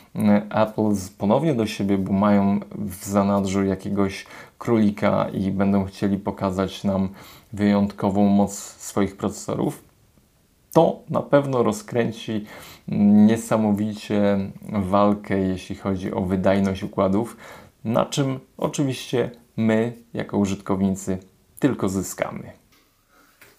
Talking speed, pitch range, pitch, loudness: 95 wpm, 95-110 Hz, 100 Hz, -22 LUFS